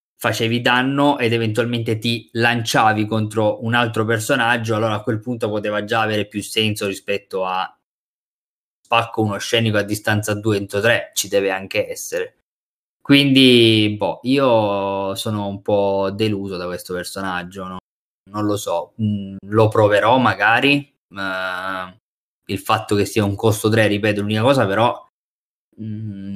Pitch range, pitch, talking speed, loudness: 100-115 Hz, 110 Hz, 145 wpm, -18 LUFS